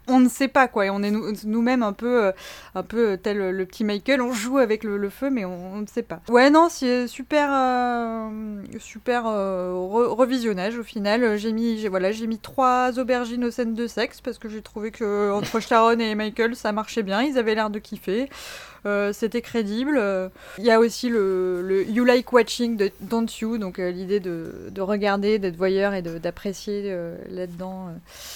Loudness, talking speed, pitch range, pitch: -23 LUFS, 205 wpm, 200-240 Hz, 220 Hz